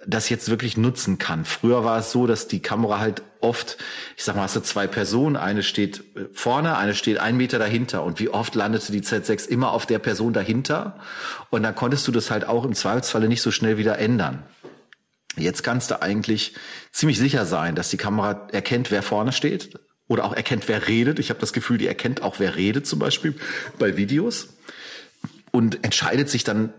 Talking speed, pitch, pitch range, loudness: 200 wpm, 110 Hz, 105-125 Hz, -22 LUFS